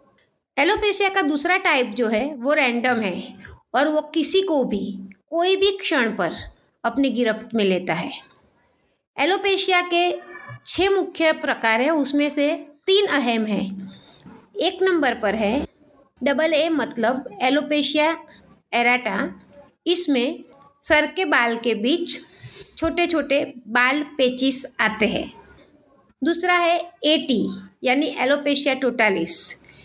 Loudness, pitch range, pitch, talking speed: -21 LUFS, 240-325 Hz, 285 Hz, 125 wpm